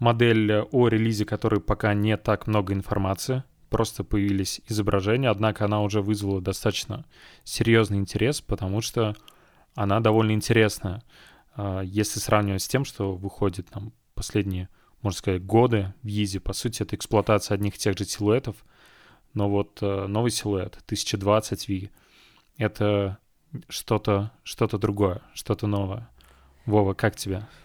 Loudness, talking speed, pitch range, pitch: -25 LUFS, 130 wpm, 100-110 Hz, 105 Hz